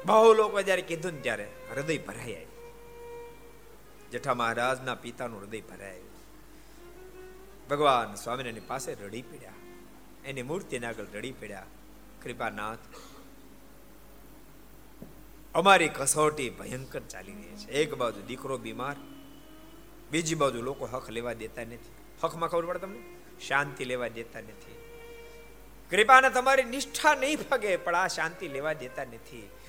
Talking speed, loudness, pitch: 105 wpm, -28 LUFS, 160 Hz